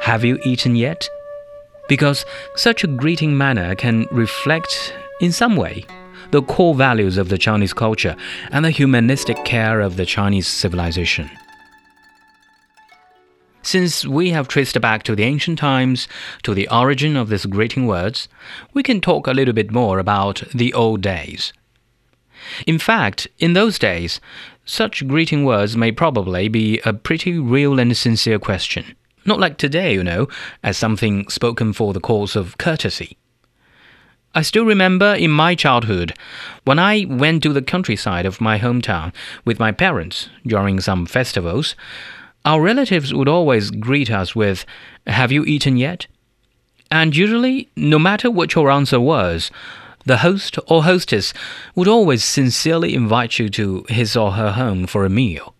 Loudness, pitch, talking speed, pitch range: -17 LUFS, 125 Hz, 155 wpm, 110-165 Hz